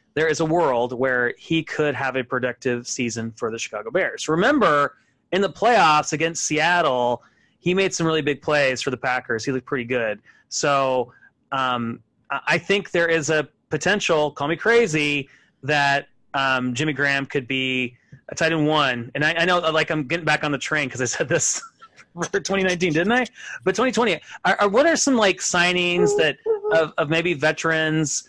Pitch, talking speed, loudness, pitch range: 155 Hz, 185 wpm, -21 LUFS, 130-175 Hz